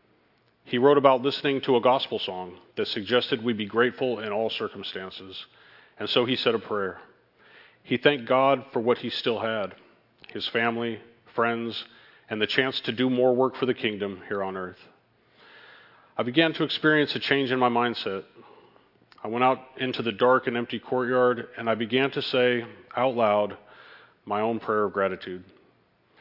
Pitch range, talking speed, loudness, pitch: 105-130 Hz, 175 wpm, -25 LUFS, 120 Hz